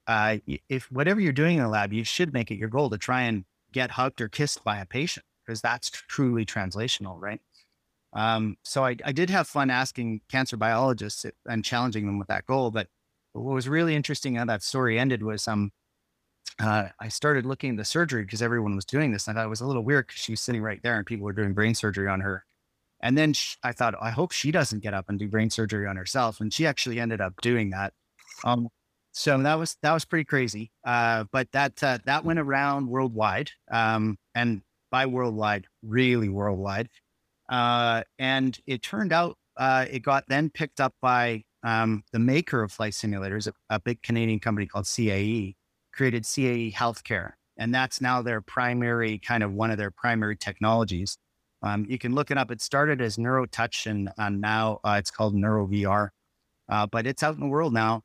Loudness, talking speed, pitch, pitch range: -27 LUFS, 210 wpm, 115 Hz, 105-130 Hz